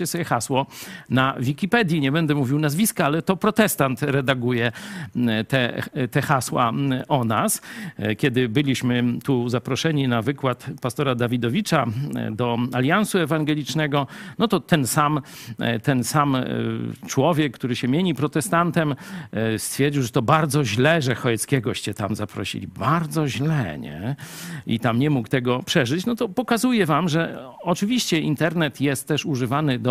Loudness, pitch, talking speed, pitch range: -22 LUFS, 140 Hz, 135 wpm, 125-160 Hz